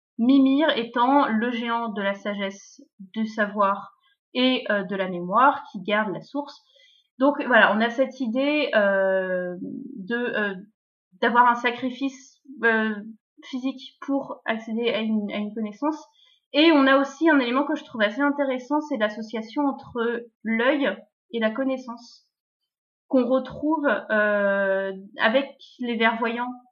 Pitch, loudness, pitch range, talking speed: 240 Hz, -23 LUFS, 215-275 Hz, 145 wpm